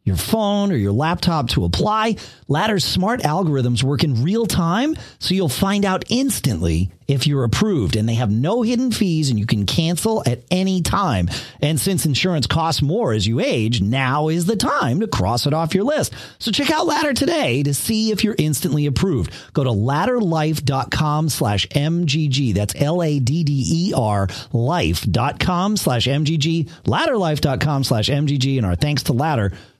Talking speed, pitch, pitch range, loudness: 165 wpm, 150 Hz, 125-185 Hz, -19 LUFS